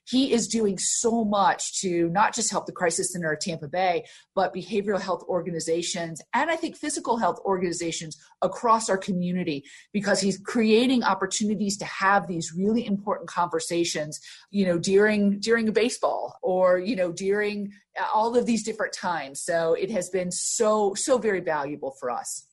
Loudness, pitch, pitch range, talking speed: -25 LUFS, 195 Hz, 175-220 Hz, 170 wpm